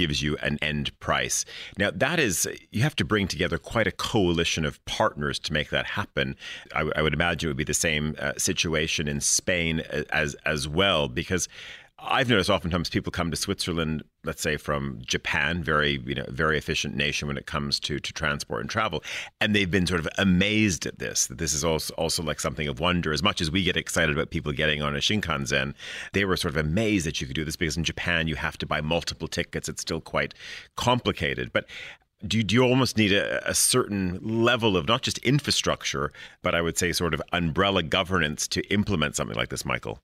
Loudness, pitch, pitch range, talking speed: -25 LUFS, 85 Hz, 75-95 Hz, 215 wpm